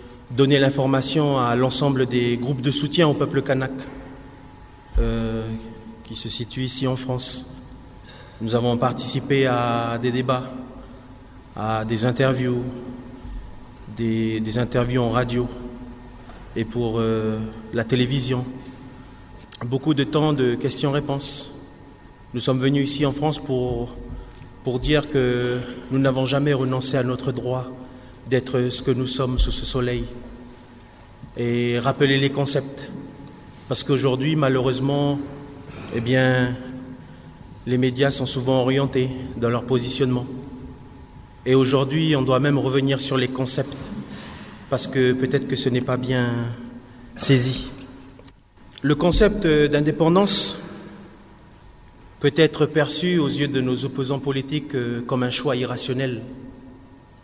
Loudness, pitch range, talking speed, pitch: -21 LUFS, 120-135 Hz, 125 wpm, 130 Hz